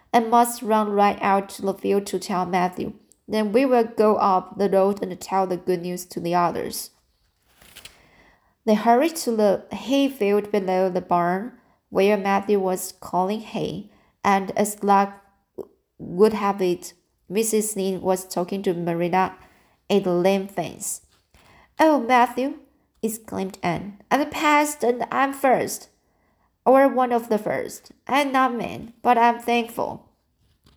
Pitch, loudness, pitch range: 200 Hz, -22 LUFS, 185-235 Hz